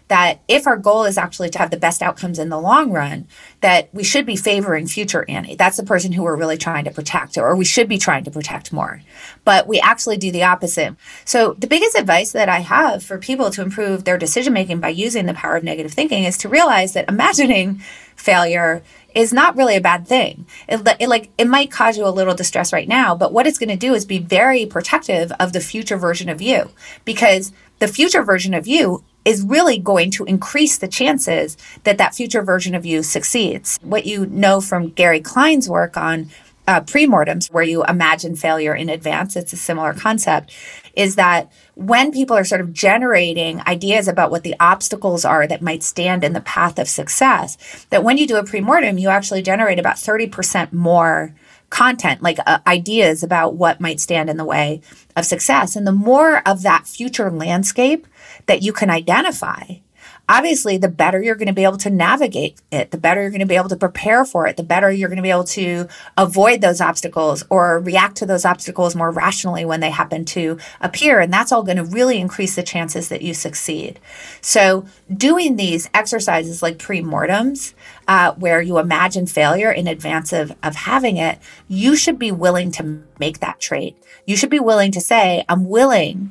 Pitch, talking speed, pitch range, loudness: 185 Hz, 205 wpm, 170-220 Hz, -16 LUFS